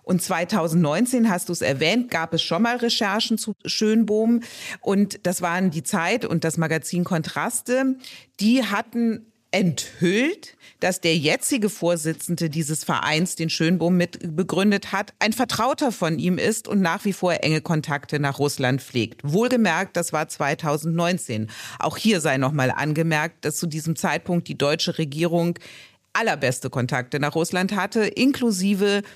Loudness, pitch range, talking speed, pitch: -22 LUFS, 160-210 Hz, 150 wpm, 175 Hz